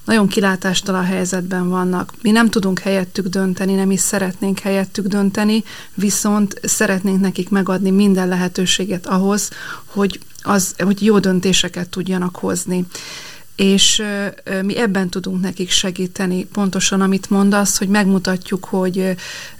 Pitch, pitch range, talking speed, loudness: 195 Hz, 185-200 Hz, 125 wpm, -17 LUFS